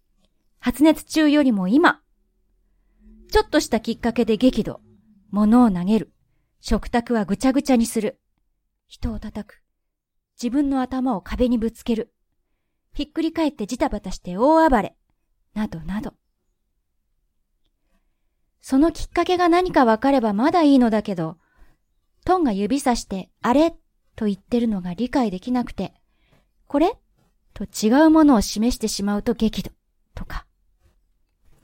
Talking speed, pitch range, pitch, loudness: 255 characters per minute, 200-275 Hz, 230 Hz, -20 LUFS